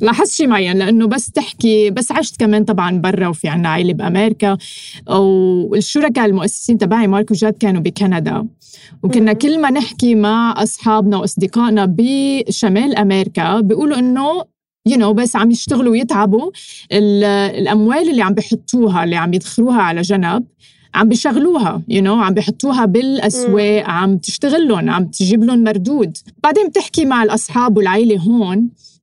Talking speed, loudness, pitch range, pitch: 145 wpm, -14 LUFS, 200-240 Hz, 215 Hz